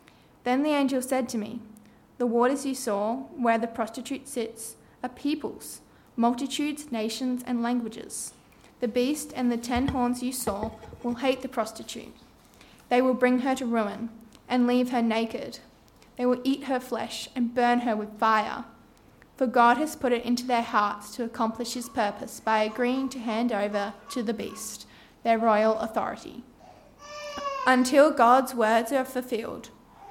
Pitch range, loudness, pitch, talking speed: 225-260 Hz, -27 LUFS, 245 Hz, 160 wpm